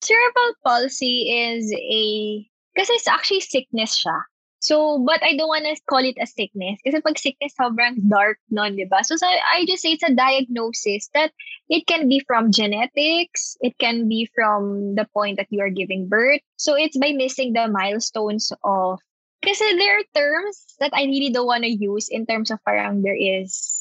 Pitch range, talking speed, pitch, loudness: 210-305 Hz, 185 wpm, 245 Hz, -20 LUFS